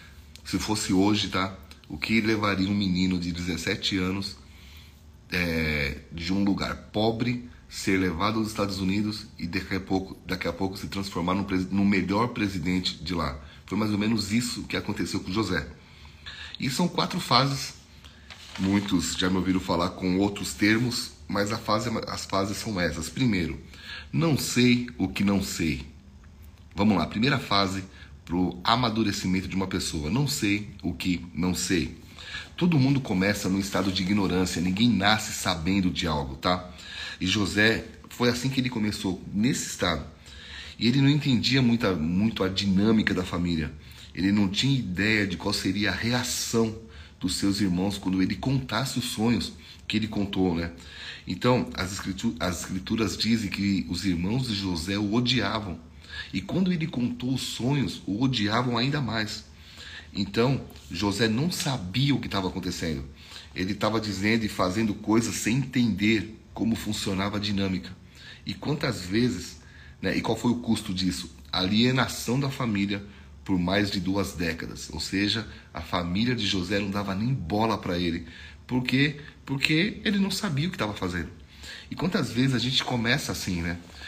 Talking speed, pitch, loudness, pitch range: 165 wpm, 100 Hz, -27 LUFS, 85-110 Hz